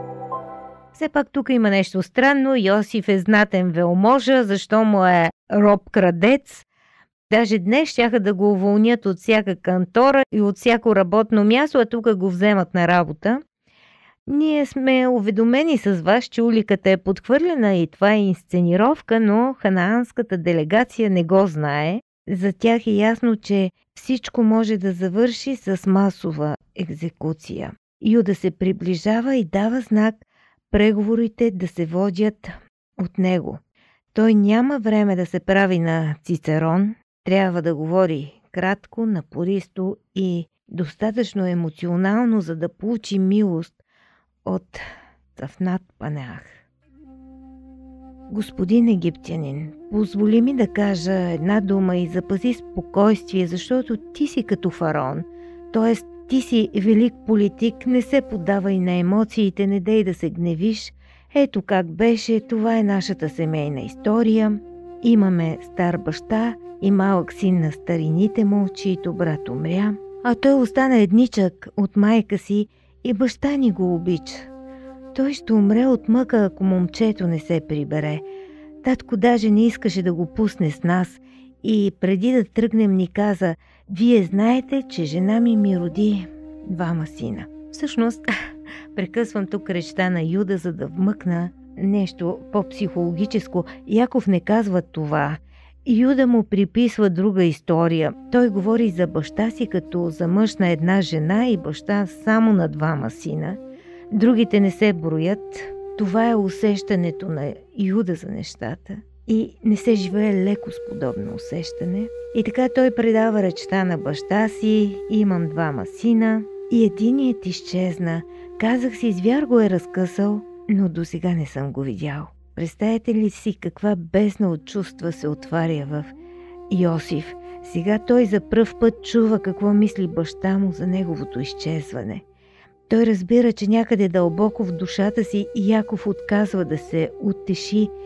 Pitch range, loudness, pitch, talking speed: 175-230 Hz, -20 LUFS, 200 Hz, 140 wpm